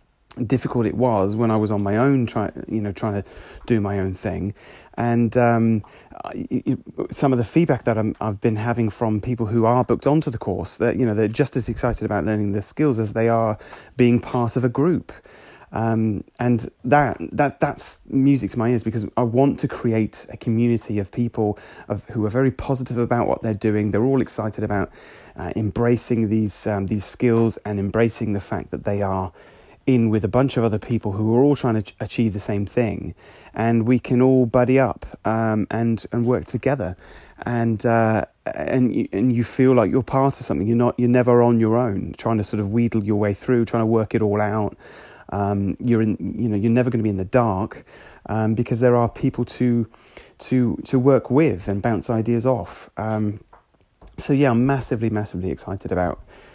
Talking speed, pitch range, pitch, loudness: 210 wpm, 105-125 Hz, 115 Hz, -21 LUFS